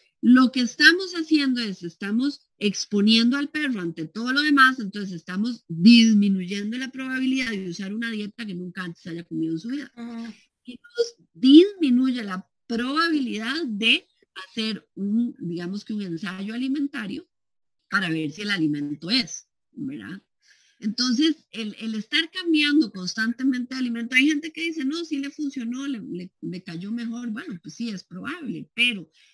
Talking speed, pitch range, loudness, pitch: 155 wpm, 200-275 Hz, -23 LUFS, 235 Hz